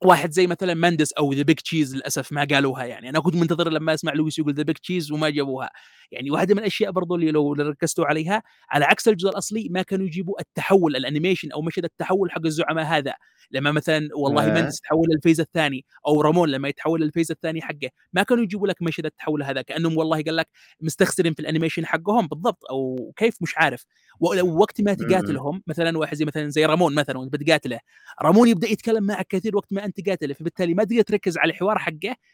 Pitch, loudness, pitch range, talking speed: 160 Hz, -22 LUFS, 150-185 Hz, 200 wpm